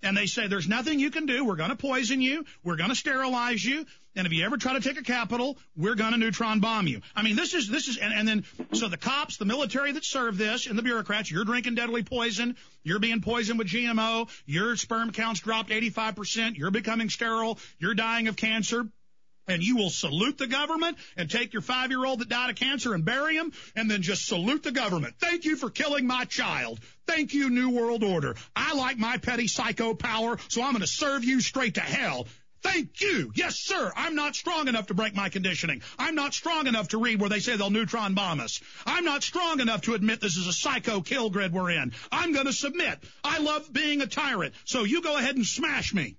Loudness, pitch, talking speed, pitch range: -27 LUFS, 235 Hz, 230 wpm, 210-270 Hz